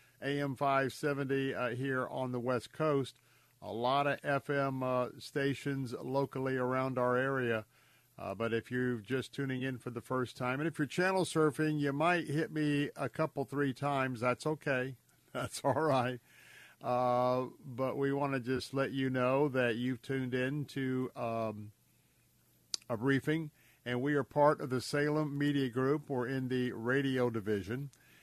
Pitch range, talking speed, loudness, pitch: 125-140 Hz, 165 wpm, -34 LUFS, 130 Hz